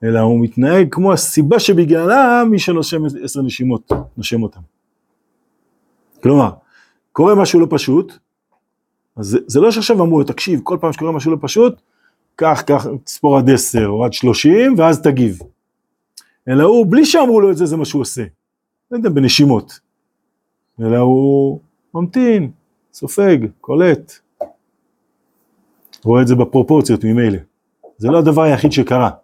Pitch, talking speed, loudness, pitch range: 145 Hz, 145 wpm, -13 LUFS, 125-180 Hz